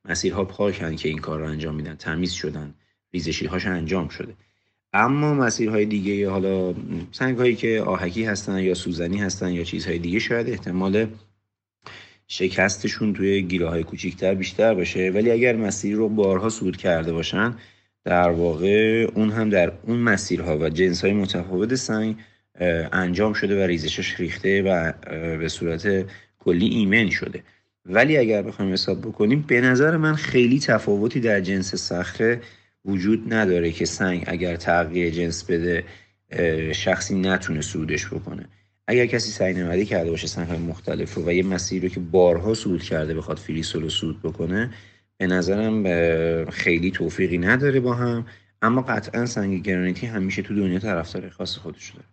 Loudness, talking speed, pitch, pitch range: -22 LUFS, 155 wpm, 95 Hz, 85-105 Hz